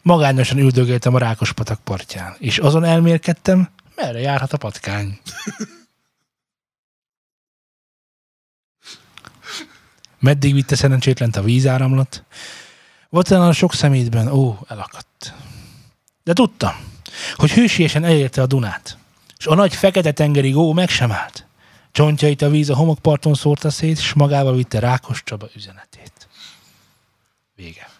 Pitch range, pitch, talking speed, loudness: 120-155 Hz, 135 Hz, 115 wpm, -16 LUFS